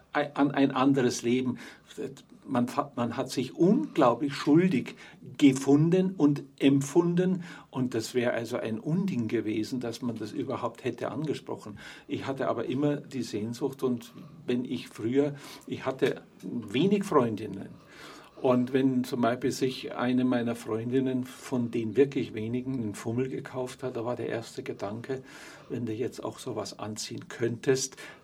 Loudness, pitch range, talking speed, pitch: -29 LUFS, 120-145 Hz, 145 wpm, 130 Hz